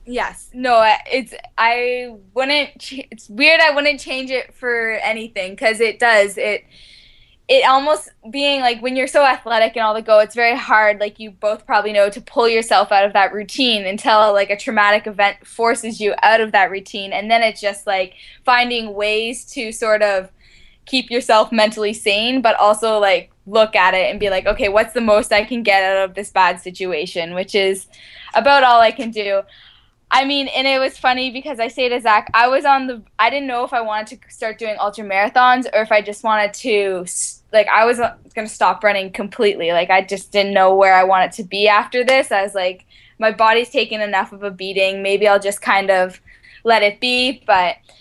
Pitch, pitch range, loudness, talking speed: 220 Hz, 200-245 Hz, -16 LUFS, 210 wpm